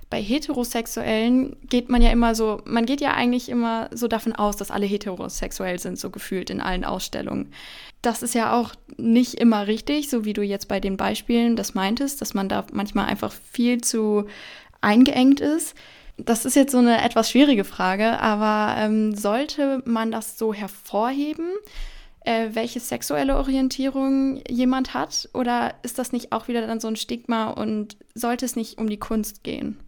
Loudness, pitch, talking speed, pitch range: -23 LUFS, 230 Hz, 175 wpm, 215-255 Hz